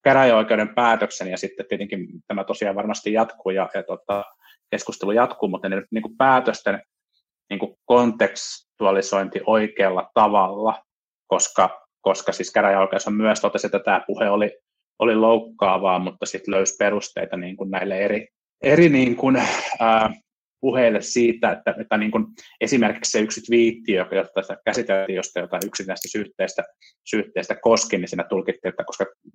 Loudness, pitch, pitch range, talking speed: -21 LUFS, 110 Hz, 95-115 Hz, 145 wpm